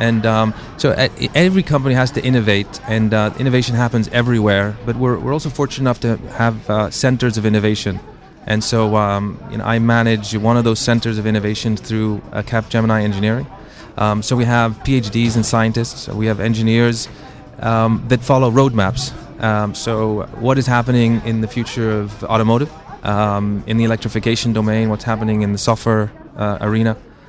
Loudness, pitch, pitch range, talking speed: -17 LUFS, 115 Hz, 110-120 Hz, 180 wpm